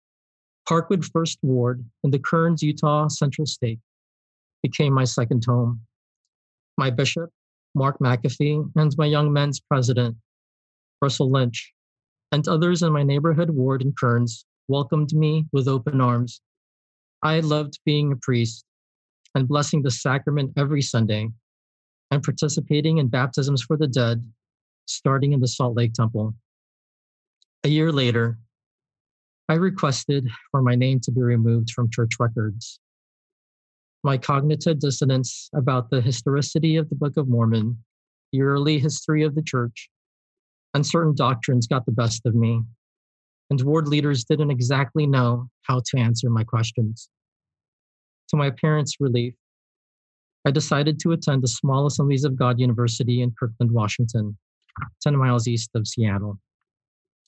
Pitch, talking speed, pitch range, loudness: 135 Hz, 140 wpm, 115-150 Hz, -22 LUFS